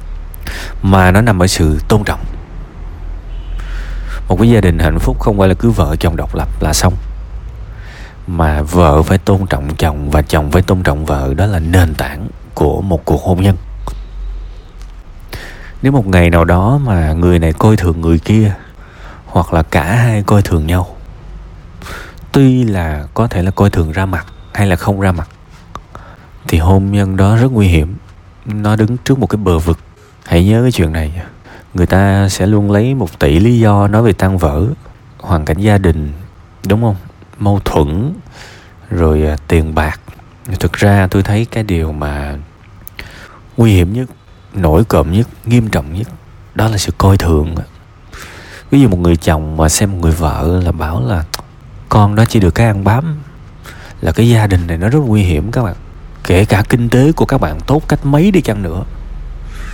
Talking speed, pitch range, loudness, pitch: 185 wpm, 80-105 Hz, -12 LUFS, 95 Hz